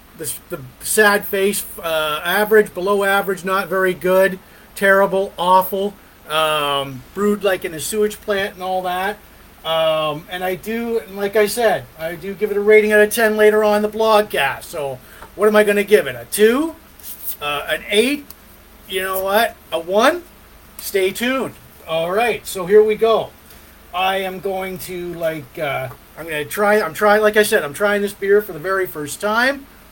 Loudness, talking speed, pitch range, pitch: -18 LUFS, 190 wpm, 180-210 Hz, 195 Hz